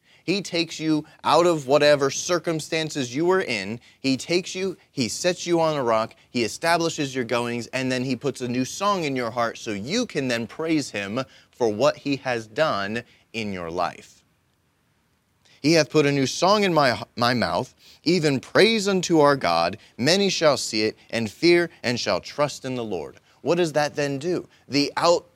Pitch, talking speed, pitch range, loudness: 145 Hz, 190 wpm, 120-170 Hz, -23 LUFS